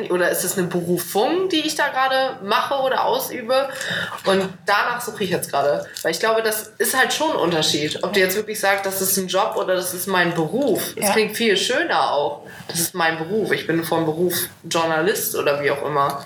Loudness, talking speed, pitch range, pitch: -20 LUFS, 220 wpm, 165-225 Hz, 190 Hz